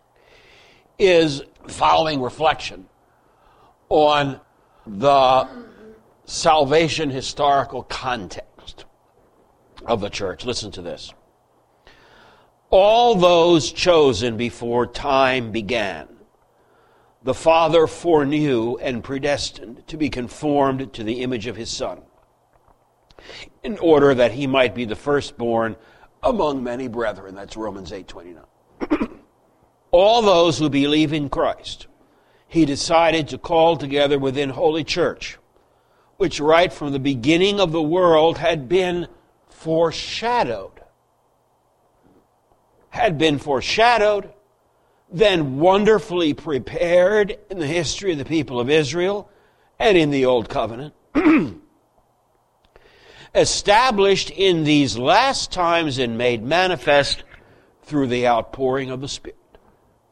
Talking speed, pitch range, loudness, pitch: 105 wpm, 130-175 Hz, -19 LUFS, 150 Hz